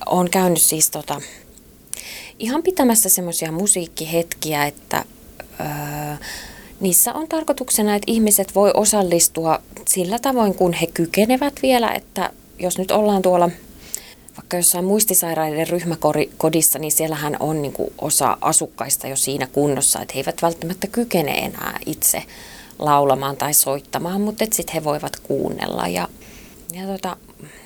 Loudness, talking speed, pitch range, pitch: -18 LUFS, 130 wpm, 155-200 Hz, 175 Hz